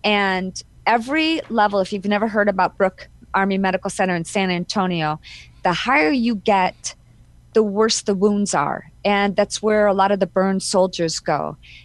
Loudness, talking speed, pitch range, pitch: -19 LUFS, 170 wpm, 185-210 Hz, 200 Hz